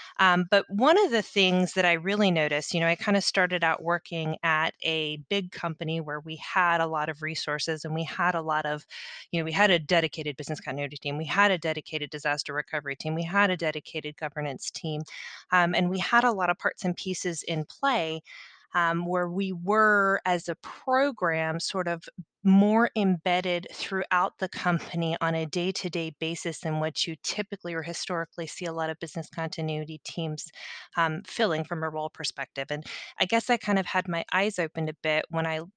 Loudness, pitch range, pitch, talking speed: -27 LUFS, 155-185 Hz, 170 Hz, 205 wpm